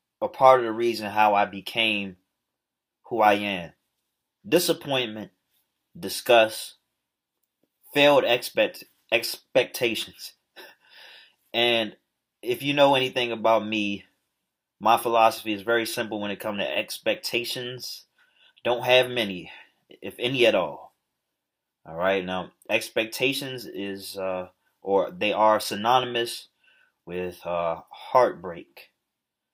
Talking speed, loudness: 110 wpm, -24 LUFS